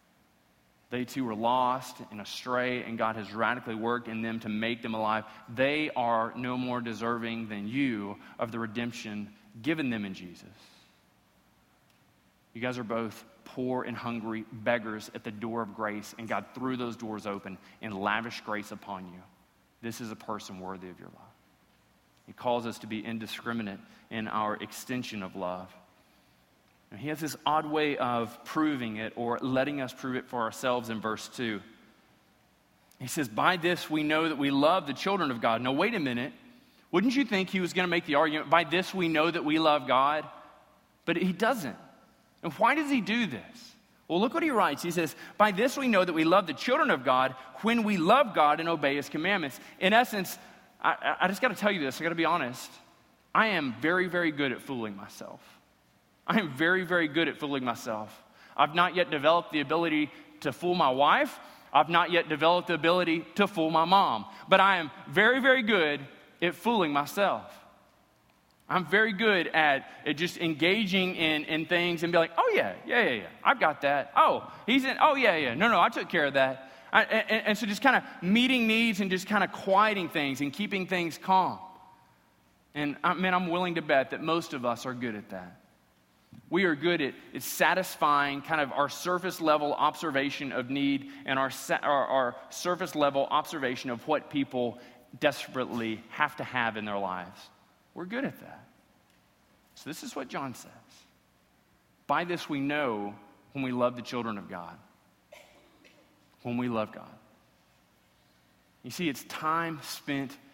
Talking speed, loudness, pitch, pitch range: 190 wpm, -28 LUFS, 140 Hz, 115-170 Hz